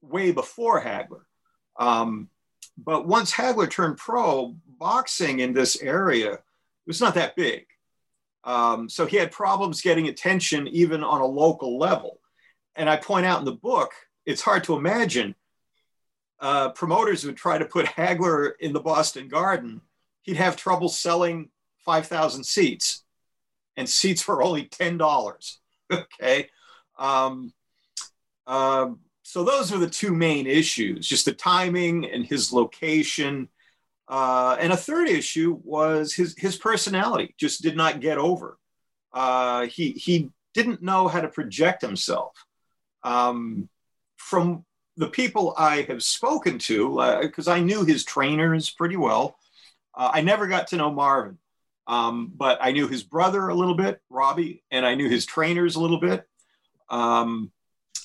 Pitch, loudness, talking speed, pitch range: 160 Hz, -23 LUFS, 150 wpm, 135-180 Hz